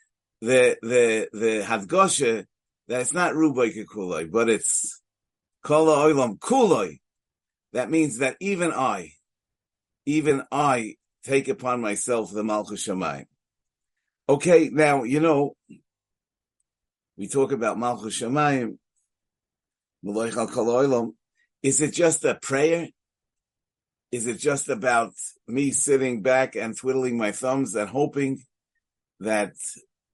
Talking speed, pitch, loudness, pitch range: 105 wpm, 130 Hz, -23 LUFS, 115-150 Hz